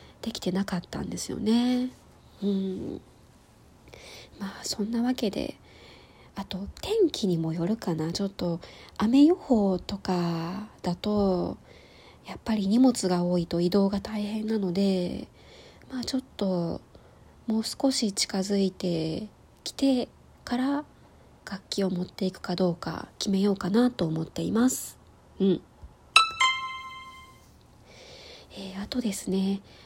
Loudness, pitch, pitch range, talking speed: -27 LUFS, 200 Hz, 185-245 Hz, 225 characters per minute